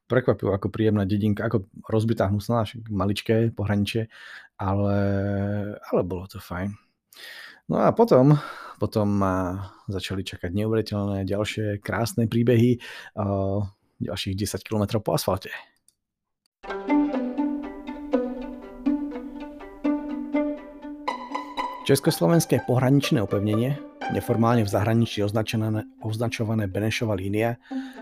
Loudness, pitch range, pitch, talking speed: -25 LUFS, 100-150 Hz, 110 Hz, 85 wpm